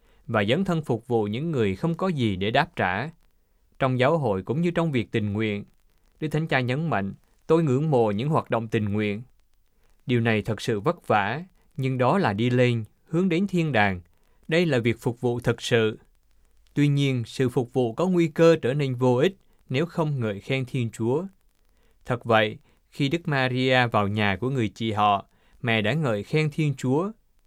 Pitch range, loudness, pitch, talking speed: 110-155 Hz, -24 LUFS, 125 Hz, 200 wpm